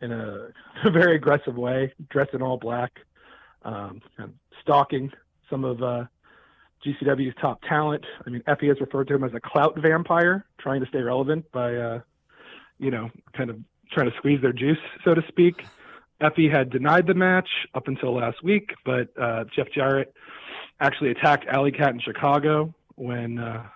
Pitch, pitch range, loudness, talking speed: 135 Hz, 125-150 Hz, -24 LUFS, 170 wpm